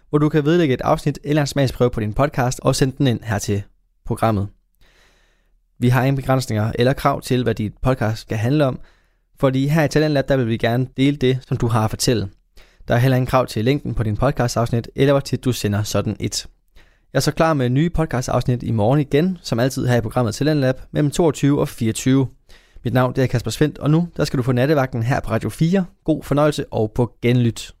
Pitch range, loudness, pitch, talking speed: 115-140 Hz, -19 LUFS, 130 Hz, 225 wpm